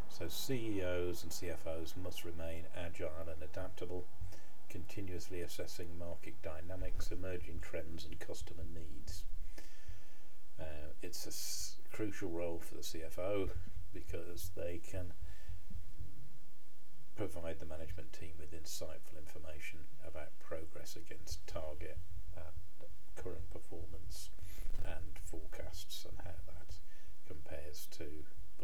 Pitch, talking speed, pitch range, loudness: 85 Hz, 105 wpm, 80-90 Hz, -47 LUFS